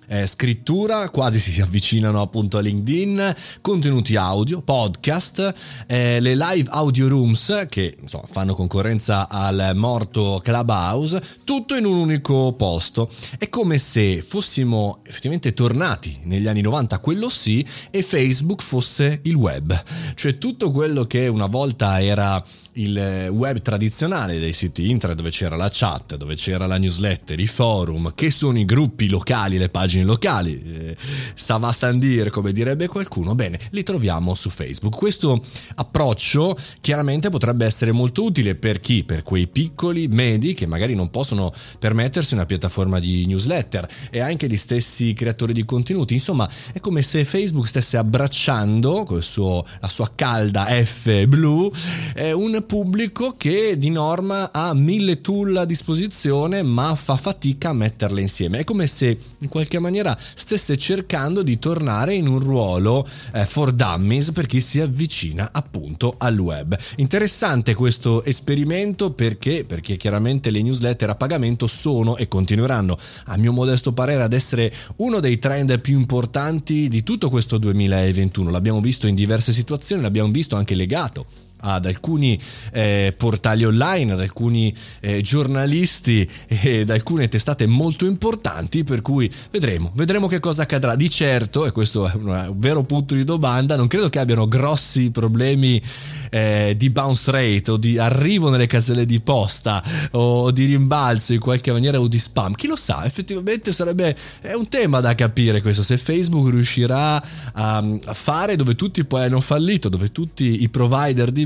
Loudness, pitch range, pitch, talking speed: -19 LUFS, 105-150 Hz, 125 Hz, 160 wpm